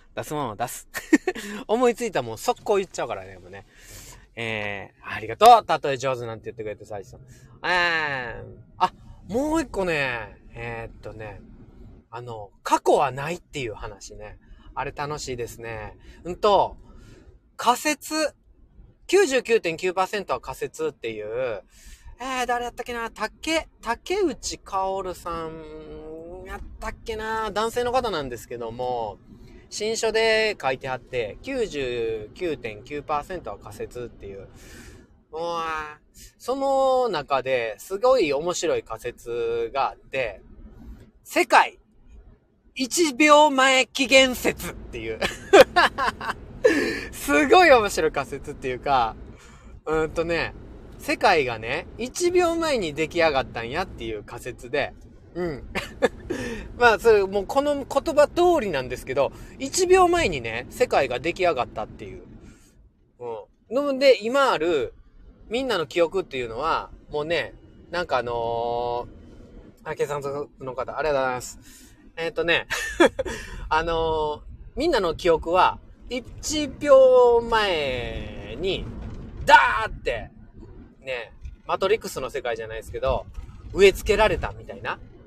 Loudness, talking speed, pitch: -23 LUFS, 245 characters per minute, 170 Hz